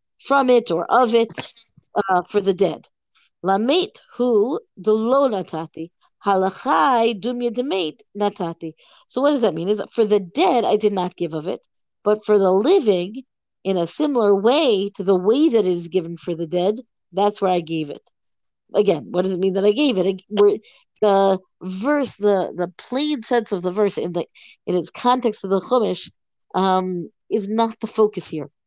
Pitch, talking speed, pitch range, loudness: 205 Hz, 180 wpm, 185-240 Hz, -20 LUFS